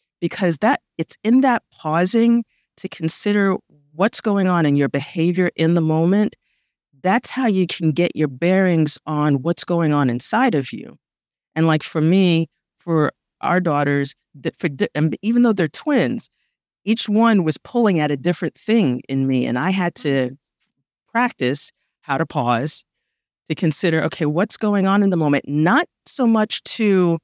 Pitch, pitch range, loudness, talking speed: 170 Hz, 150-205 Hz, -19 LUFS, 165 wpm